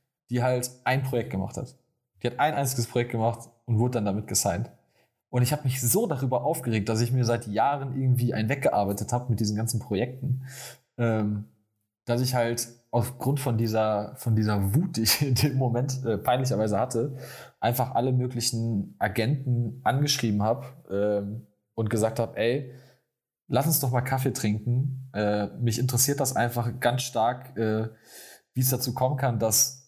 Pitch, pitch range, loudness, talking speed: 120 Hz, 110-130 Hz, -26 LUFS, 175 wpm